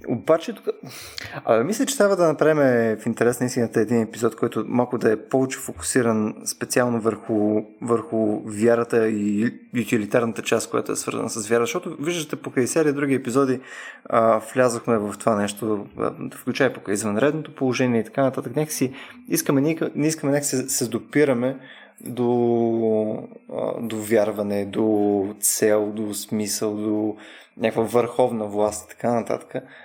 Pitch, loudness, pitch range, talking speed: 115 Hz, -22 LUFS, 110-135 Hz, 145 wpm